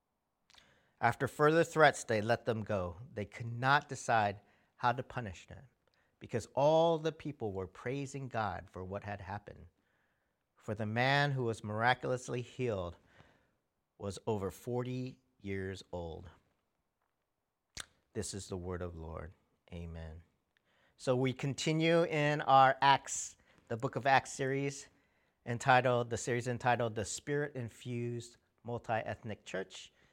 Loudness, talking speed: -34 LUFS, 130 wpm